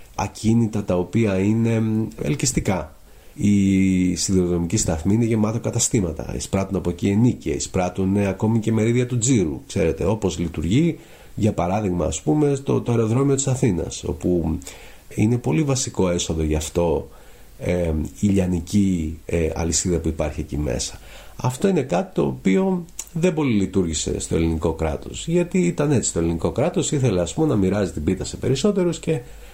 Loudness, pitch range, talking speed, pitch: -21 LUFS, 85-120 Hz, 155 wpm, 100 Hz